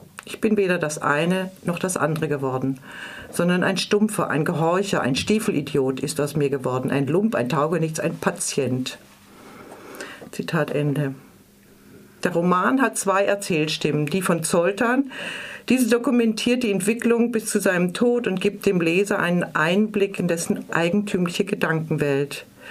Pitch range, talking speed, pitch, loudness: 155-210 Hz, 145 wpm, 180 Hz, -22 LUFS